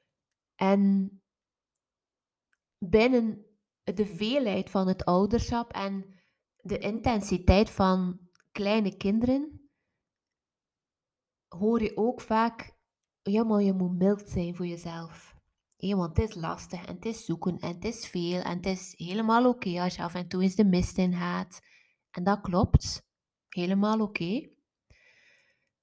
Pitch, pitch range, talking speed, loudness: 195 Hz, 180-220 Hz, 135 wpm, -28 LUFS